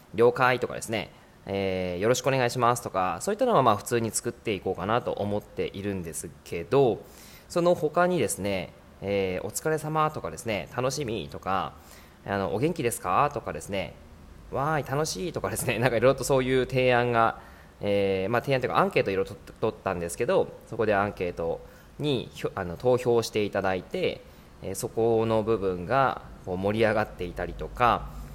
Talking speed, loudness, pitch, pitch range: 375 characters per minute, -27 LUFS, 105 Hz, 95-125 Hz